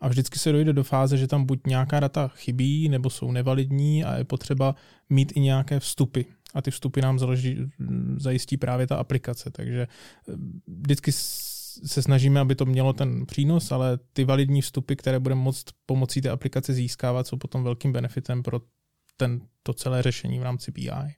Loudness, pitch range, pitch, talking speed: -25 LUFS, 125-140 Hz, 135 Hz, 175 wpm